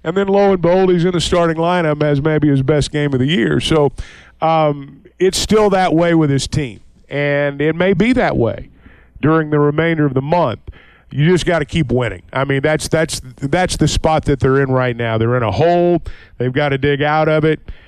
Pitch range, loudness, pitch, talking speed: 135-170 Hz, -15 LUFS, 150 Hz, 230 wpm